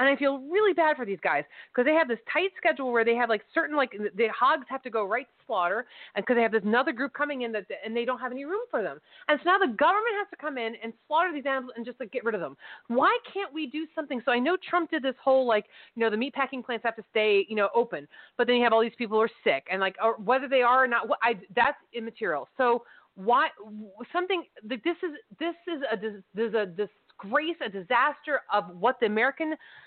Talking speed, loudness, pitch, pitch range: 260 wpm, -27 LUFS, 245 Hz, 225-300 Hz